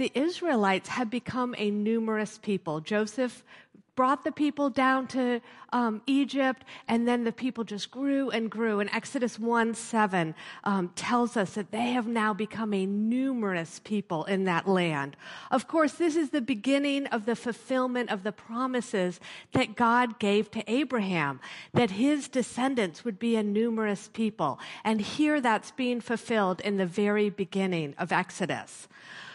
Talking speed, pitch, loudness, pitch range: 160 wpm, 230 Hz, -29 LUFS, 205-255 Hz